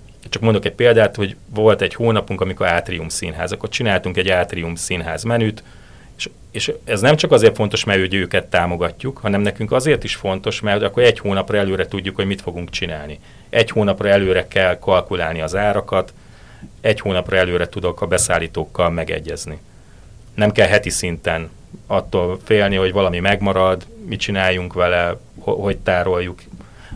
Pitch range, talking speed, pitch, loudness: 90-105 Hz, 160 wpm, 95 Hz, -18 LUFS